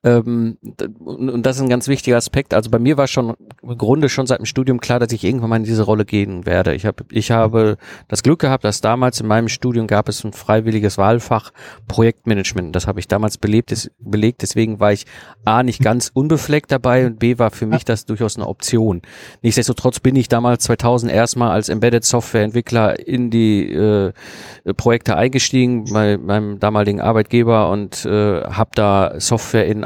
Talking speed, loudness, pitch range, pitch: 185 wpm, -16 LUFS, 105-120 Hz, 115 Hz